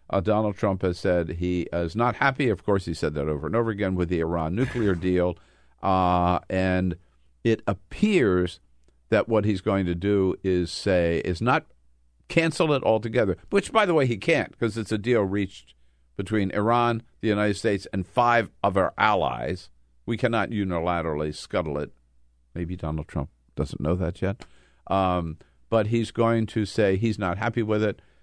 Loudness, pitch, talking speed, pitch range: -25 LUFS, 95 Hz, 180 wpm, 85-110 Hz